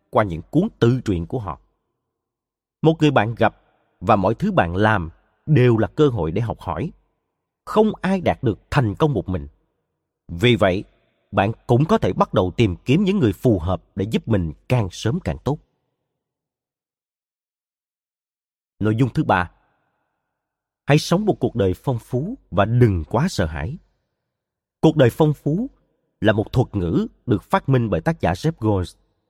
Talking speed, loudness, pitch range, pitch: 170 wpm, -20 LUFS, 105-150 Hz, 115 Hz